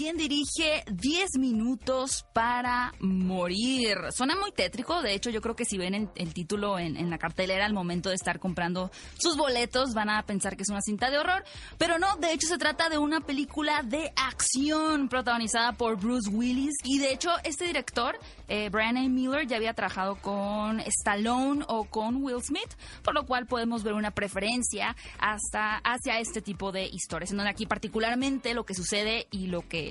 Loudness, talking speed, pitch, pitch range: -29 LUFS, 190 wpm, 230 Hz, 200-275 Hz